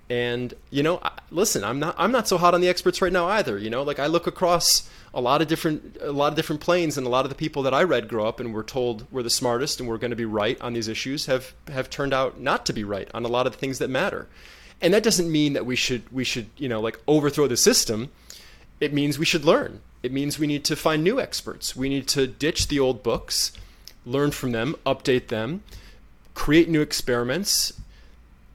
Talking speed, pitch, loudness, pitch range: 245 wpm, 135 Hz, -23 LUFS, 120-155 Hz